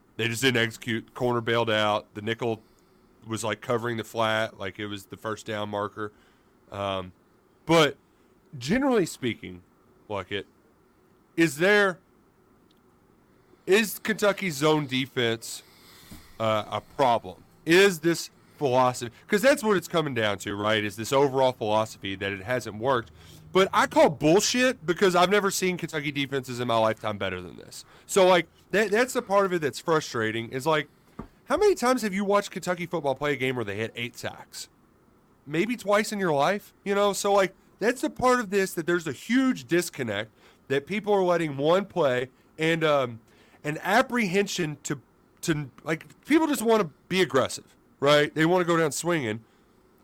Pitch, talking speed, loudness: 150 Hz, 175 wpm, -25 LUFS